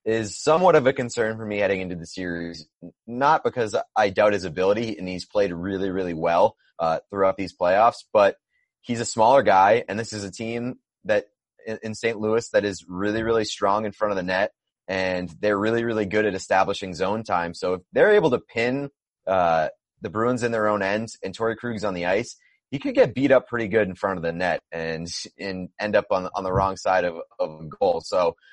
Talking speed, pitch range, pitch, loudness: 220 wpm, 95-115 Hz, 105 Hz, -23 LUFS